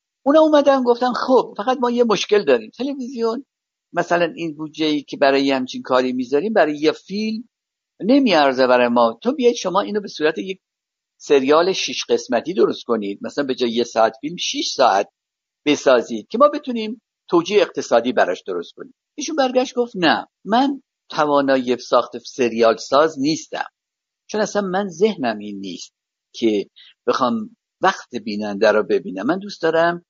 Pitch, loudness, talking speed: 195 Hz, -19 LUFS, 155 wpm